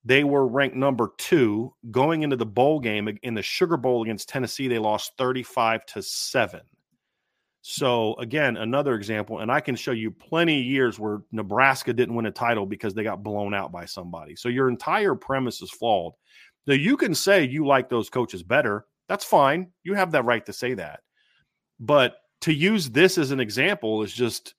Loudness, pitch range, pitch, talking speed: -24 LUFS, 110-140 Hz, 125 Hz, 195 wpm